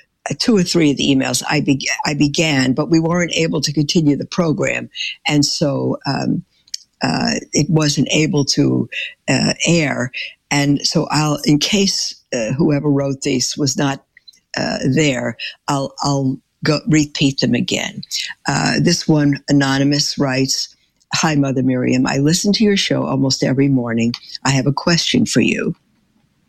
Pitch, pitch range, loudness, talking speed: 145 Hz, 135-155 Hz, -16 LUFS, 160 wpm